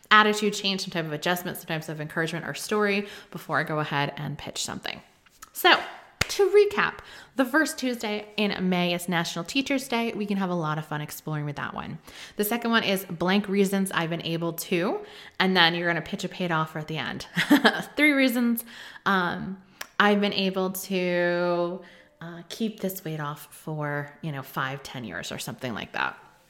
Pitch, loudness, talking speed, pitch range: 180 Hz, -26 LUFS, 195 wpm, 160-205 Hz